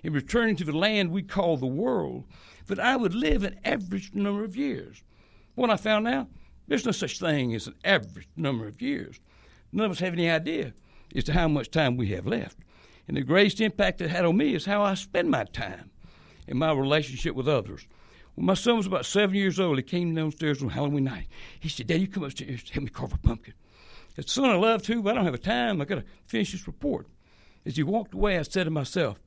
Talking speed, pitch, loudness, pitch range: 240 wpm, 175 Hz, -27 LUFS, 140-205 Hz